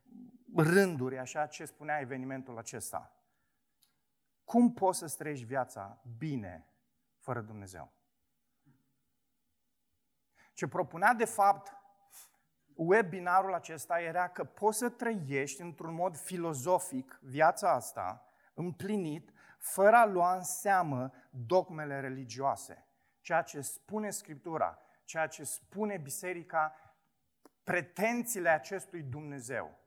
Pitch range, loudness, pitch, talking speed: 135-190 Hz, -33 LUFS, 165 Hz, 100 wpm